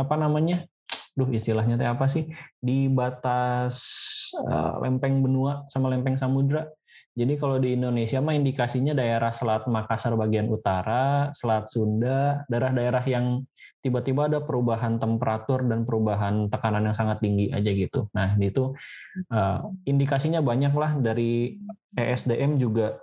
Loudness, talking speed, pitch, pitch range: -25 LUFS, 130 wpm, 125 Hz, 115-140 Hz